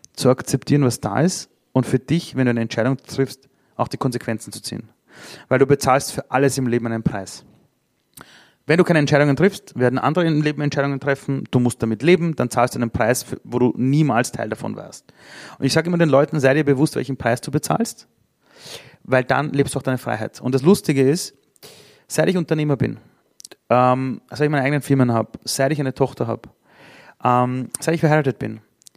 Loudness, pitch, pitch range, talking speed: -20 LUFS, 135 Hz, 125-150 Hz, 205 wpm